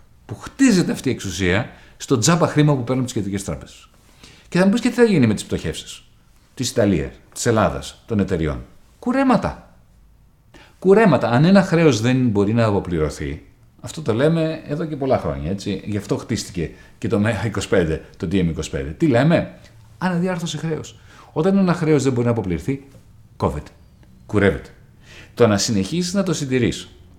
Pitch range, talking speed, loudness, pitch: 100-160 Hz, 165 wpm, -19 LUFS, 120 Hz